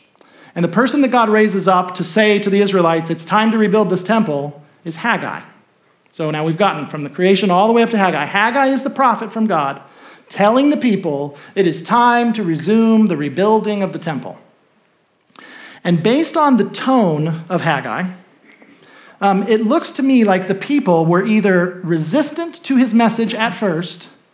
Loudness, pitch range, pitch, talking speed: -15 LUFS, 170-230 Hz, 200 Hz, 185 wpm